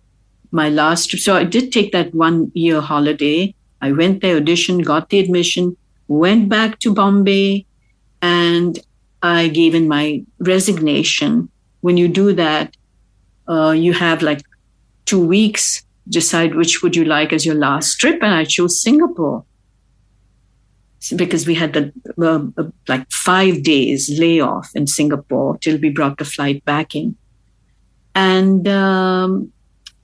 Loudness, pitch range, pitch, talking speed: -15 LUFS, 150-185 Hz, 165 Hz, 140 wpm